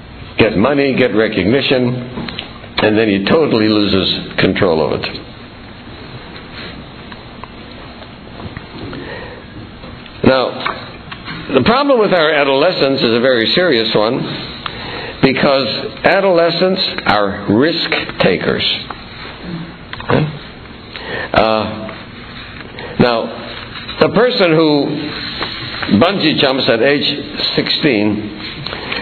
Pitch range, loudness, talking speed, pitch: 110-145 Hz, -14 LUFS, 80 wpm, 120 Hz